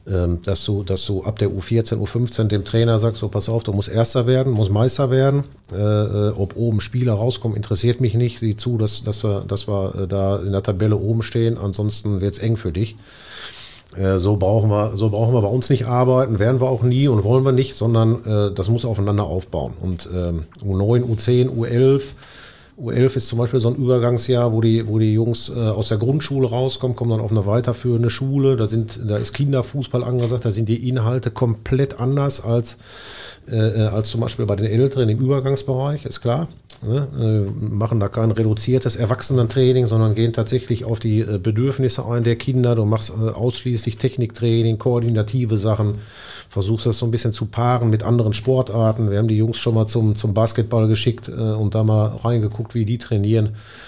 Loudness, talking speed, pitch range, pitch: -19 LUFS, 190 wpm, 105-125 Hz, 115 Hz